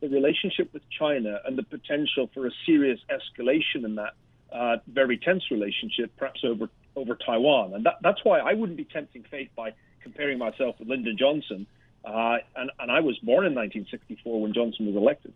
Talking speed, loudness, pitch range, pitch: 190 wpm, -26 LUFS, 115-150 Hz, 130 Hz